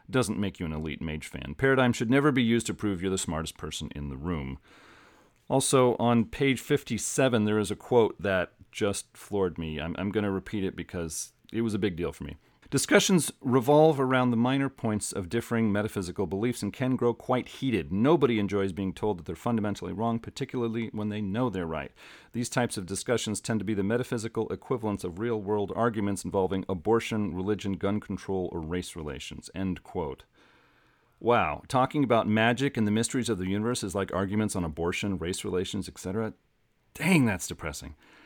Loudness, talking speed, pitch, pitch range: -28 LUFS, 190 wpm, 105 Hz, 95-120 Hz